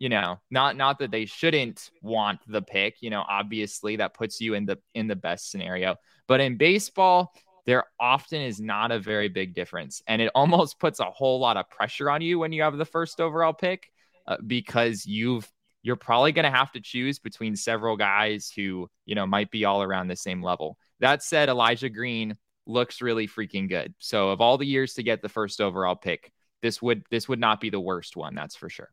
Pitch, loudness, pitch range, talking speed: 115 Hz, -26 LUFS, 105-135 Hz, 220 wpm